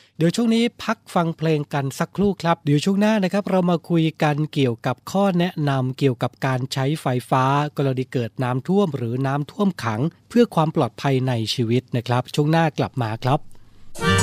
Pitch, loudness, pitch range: 145 Hz, -21 LUFS, 125-170 Hz